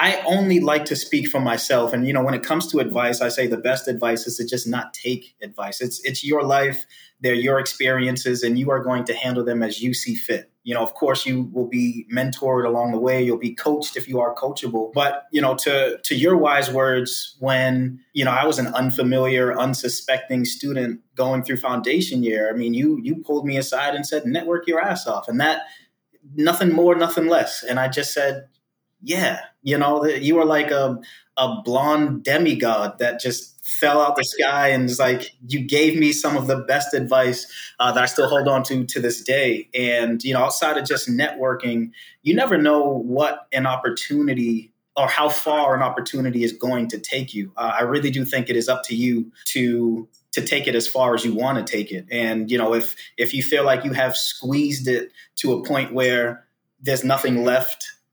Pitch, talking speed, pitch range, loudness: 130 Hz, 215 wpm, 120-140 Hz, -21 LUFS